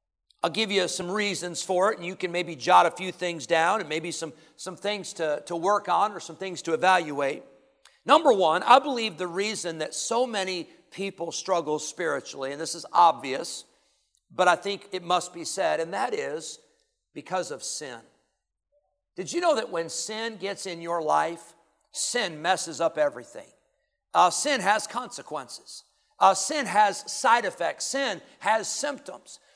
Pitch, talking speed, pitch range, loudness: 185 Hz, 175 wpm, 170-220 Hz, -26 LUFS